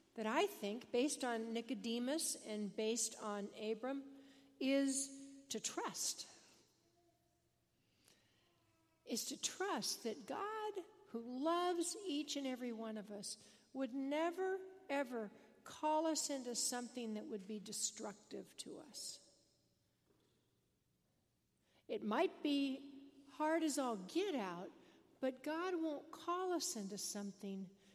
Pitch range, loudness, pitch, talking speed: 215-310 Hz, -42 LUFS, 260 Hz, 115 wpm